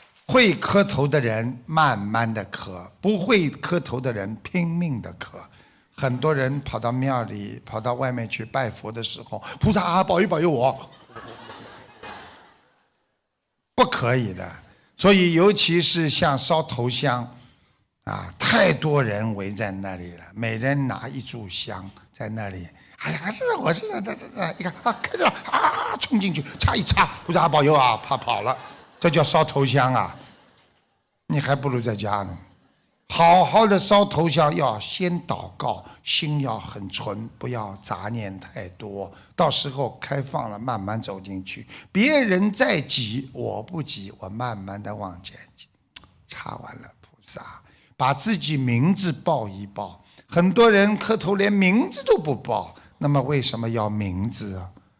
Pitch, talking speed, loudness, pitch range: 130 Hz, 210 characters per minute, -22 LUFS, 105-165 Hz